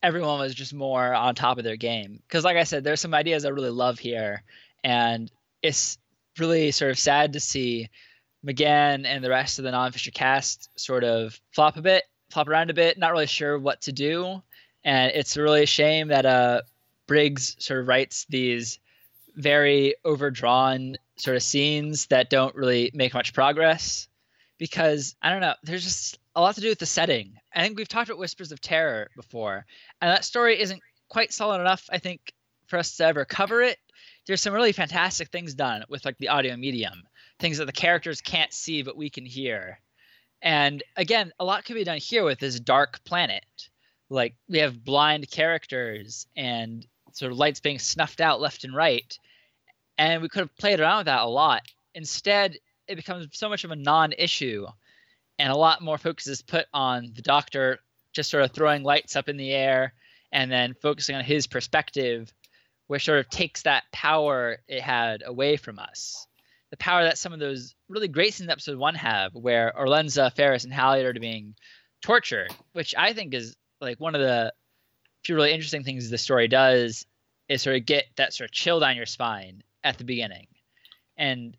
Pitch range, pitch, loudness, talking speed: 125-160 Hz, 145 Hz, -24 LUFS, 195 wpm